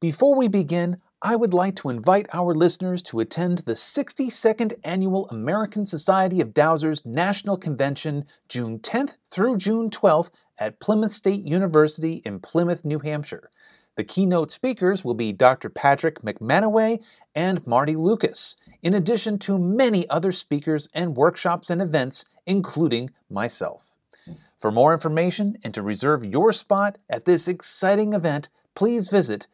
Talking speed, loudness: 145 wpm, -22 LUFS